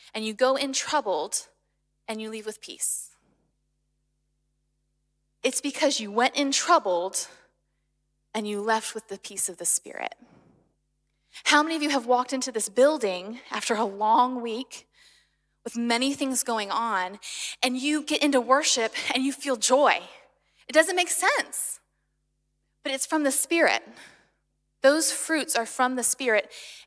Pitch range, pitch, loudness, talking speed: 220-285 Hz, 255 Hz, -25 LUFS, 150 wpm